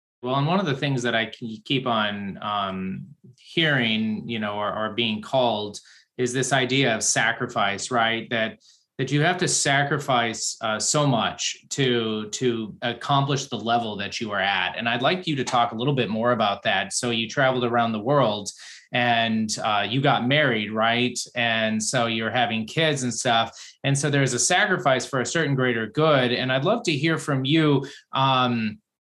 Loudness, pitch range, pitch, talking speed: -23 LUFS, 110-140 Hz, 120 Hz, 190 wpm